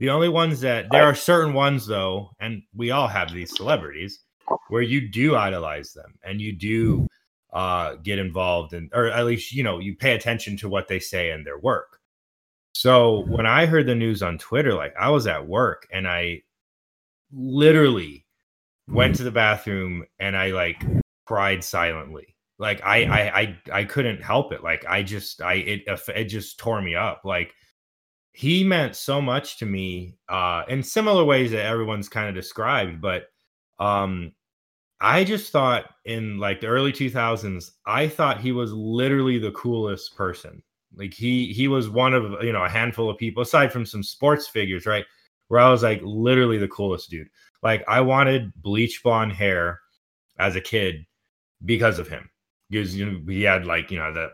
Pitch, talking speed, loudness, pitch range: 105 Hz, 185 wpm, -22 LUFS, 95-125 Hz